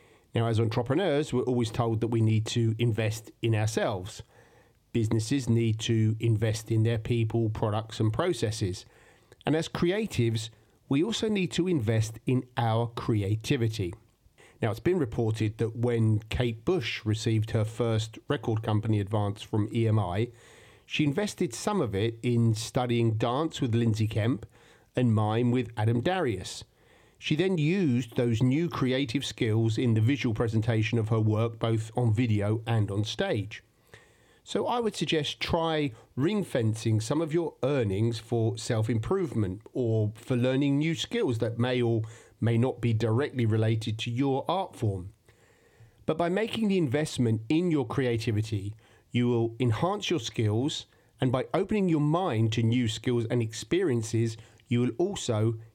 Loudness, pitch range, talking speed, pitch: -28 LUFS, 110-130 Hz, 155 wpm, 115 Hz